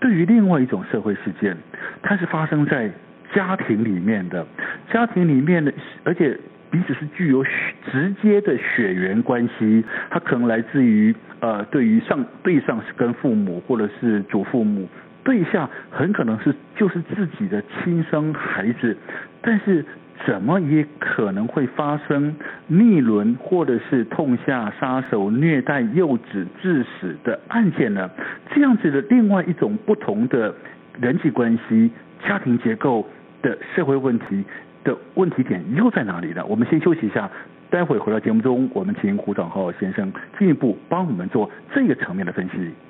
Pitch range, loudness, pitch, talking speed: 130-205 Hz, -20 LUFS, 165 Hz, 250 characters per minute